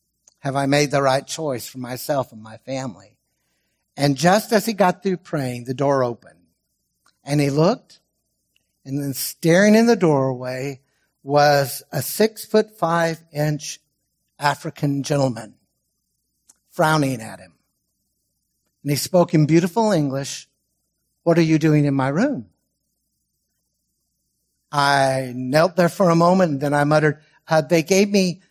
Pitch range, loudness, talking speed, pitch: 135-170 Hz, -19 LUFS, 145 wpm, 145 Hz